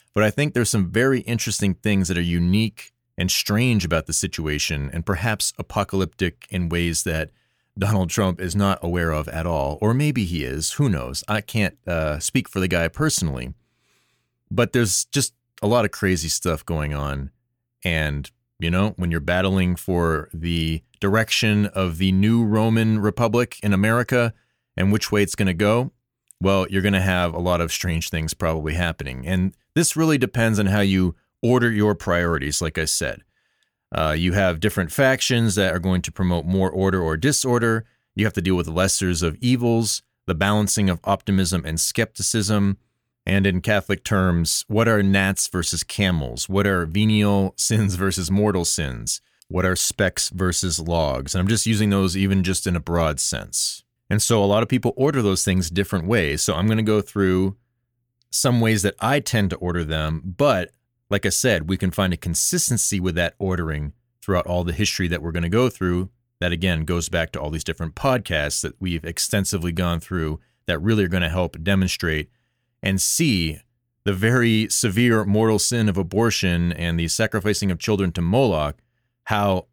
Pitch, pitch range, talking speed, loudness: 95 Hz, 85-110 Hz, 185 wpm, -21 LUFS